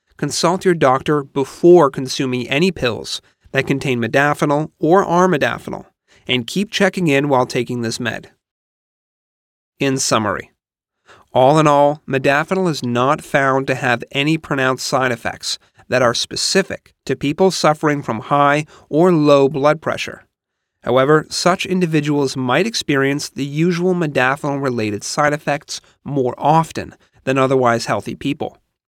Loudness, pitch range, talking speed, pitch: -17 LUFS, 130-160 Hz, 130 wpm, 140 Hz